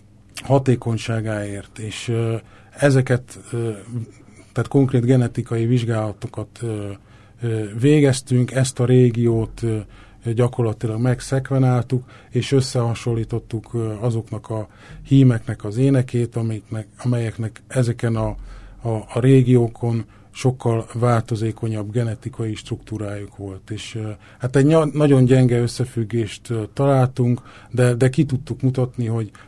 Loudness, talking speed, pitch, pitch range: -20 LUFS, 90 wpm, 115 Hz, 110-125 Hz